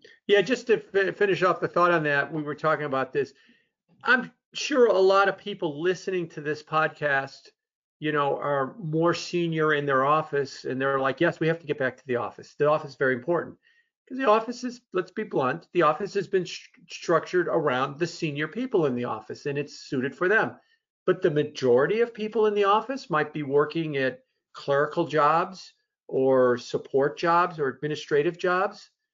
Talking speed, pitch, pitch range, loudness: 200 wpm, 170 Hz, 145-205 Hz, -25 LUFS